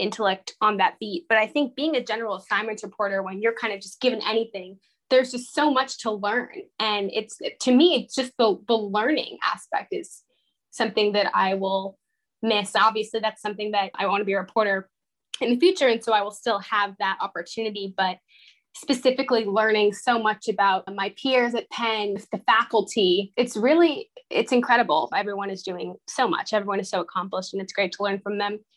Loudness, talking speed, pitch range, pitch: -24 LUFS, 195 wpm, 200-240 Hz, 215 Hz